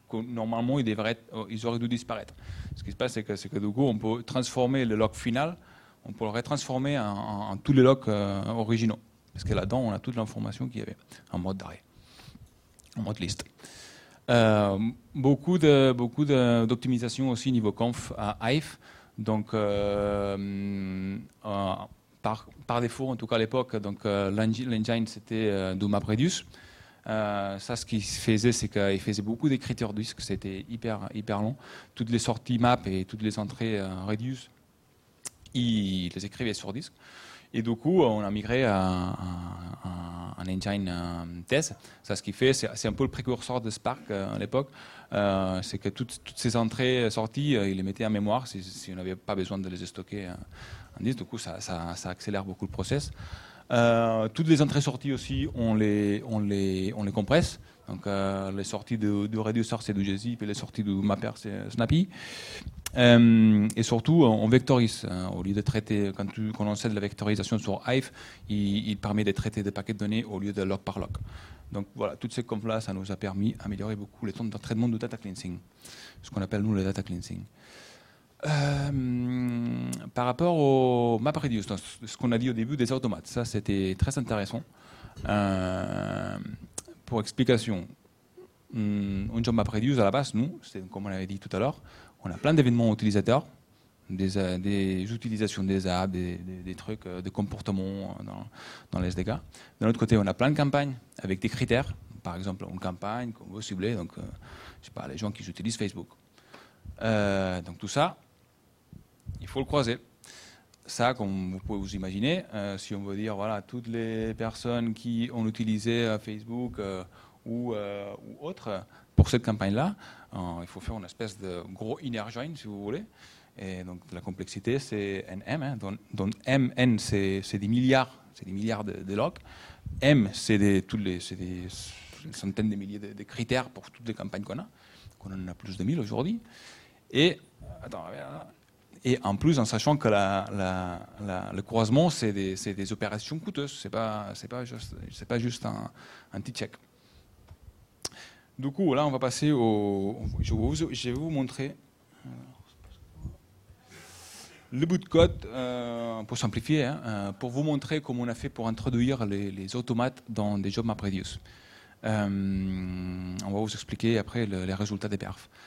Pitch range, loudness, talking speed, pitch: 100-120 Hz, -29 LUFS, 185 wpm, 110 Hz